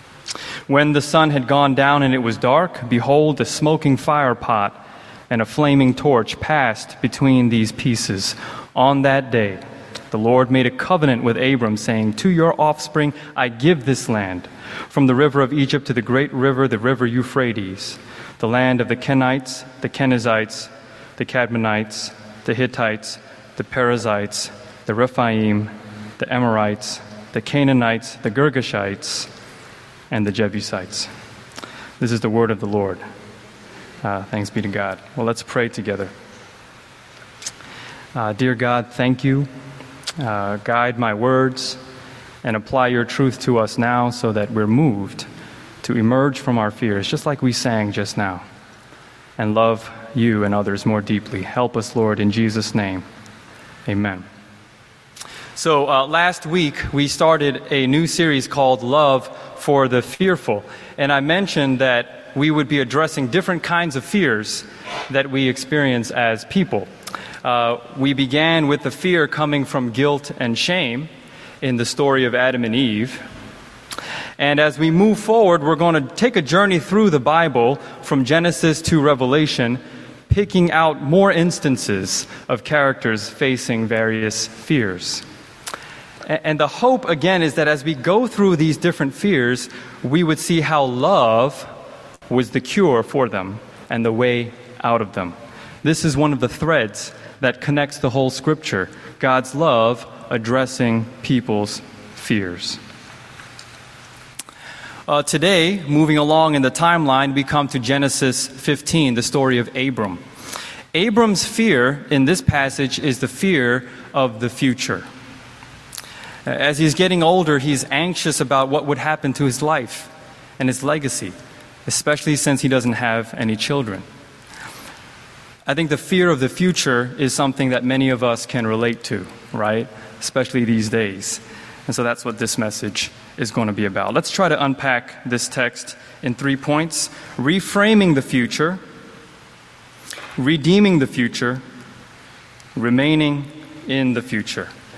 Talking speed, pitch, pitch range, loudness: 150 wpm, 130 Hz, 115-150 Hz, -18 LUFS